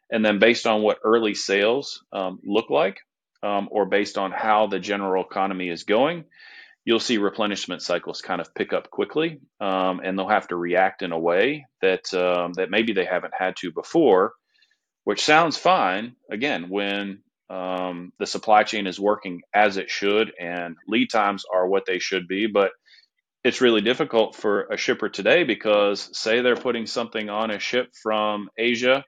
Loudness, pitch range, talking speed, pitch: -23 LUFS, 95-110 Hz, 180 wpm, 100 Hz